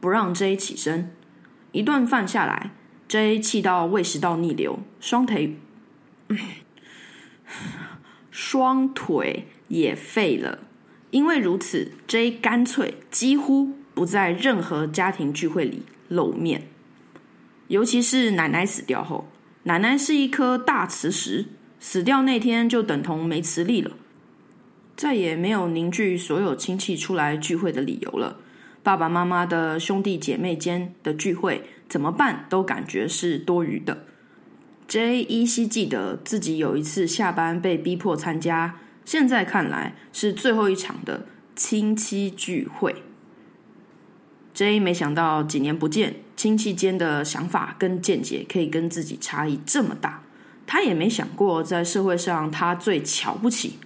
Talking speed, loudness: 205 characters per minute, -23 LUFS